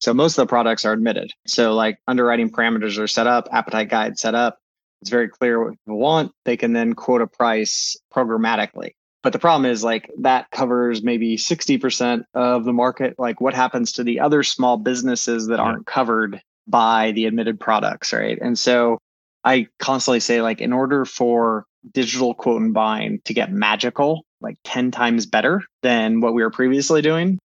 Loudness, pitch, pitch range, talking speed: -19 LUFS, 120 Hz, 115-125 Hz, 185 wpm